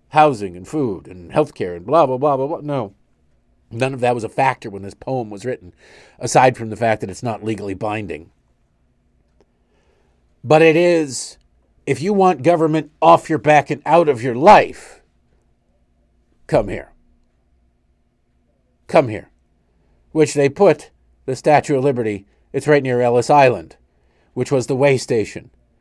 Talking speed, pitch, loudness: 160 wpm, 120 Hz, -17 LUFS